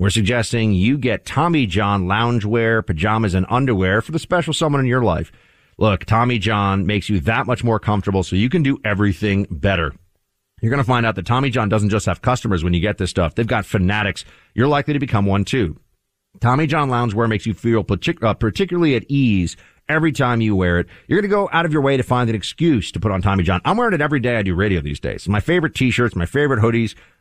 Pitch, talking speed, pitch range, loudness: 110 Hz, 235 wpm, 100-125 Hz, -18 LUFS